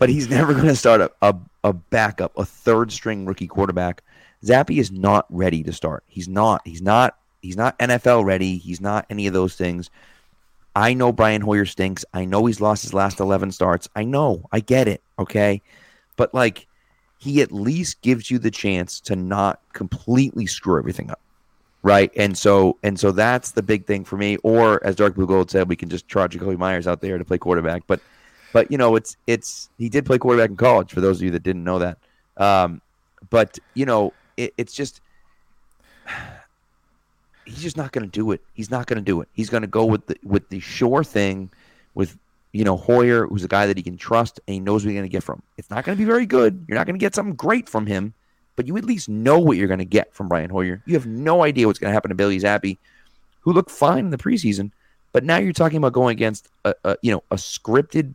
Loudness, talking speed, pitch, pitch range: -20 LUFS, 235 wpm, 105 Hz, 95-120 Hz